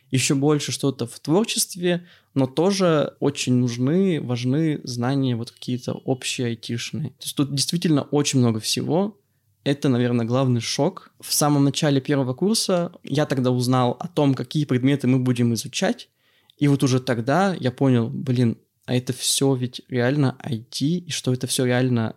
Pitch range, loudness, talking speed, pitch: 125-150 Hz, -22 LUFS, 160 wpm, 135 Hz